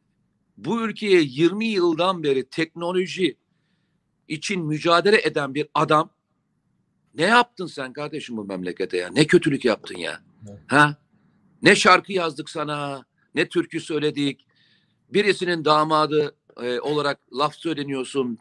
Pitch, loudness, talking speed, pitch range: 155 Hz, -22 LUFS, 115 wpm, 145-180 Hz